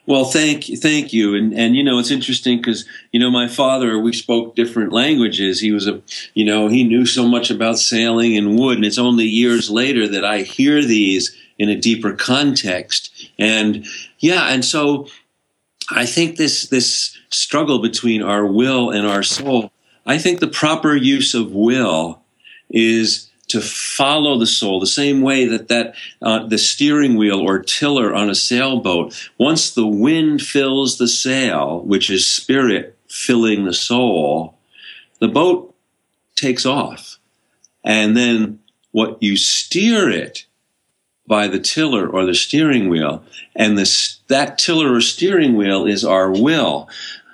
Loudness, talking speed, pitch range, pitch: -15 LUFS, 160 wpm, 105-130 Hz, 115 Hz